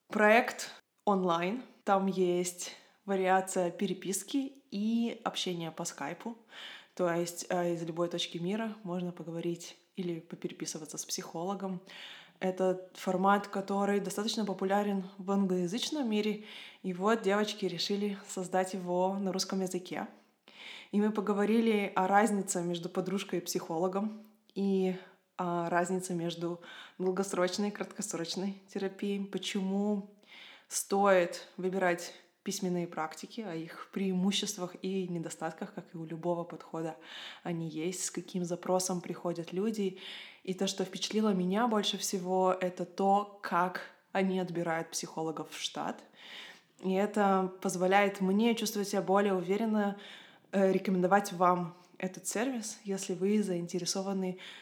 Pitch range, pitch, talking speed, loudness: 180-200 Hz, 190 Hz, 120 wpm, -33 LUFS